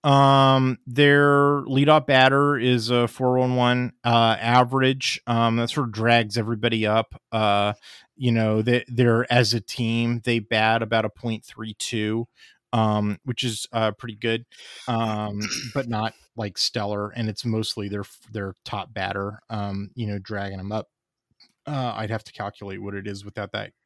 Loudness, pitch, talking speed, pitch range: -22 LUFS, 115 Hz, 165 wpm, 105-125 Hz